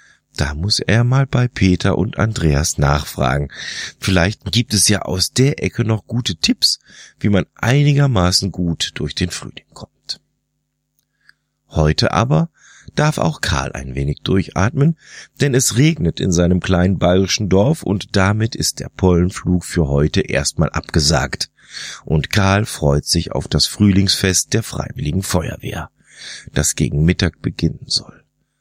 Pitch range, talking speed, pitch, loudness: 80-105 Hz, 140 wpm, 95 Hz, -17 LUFS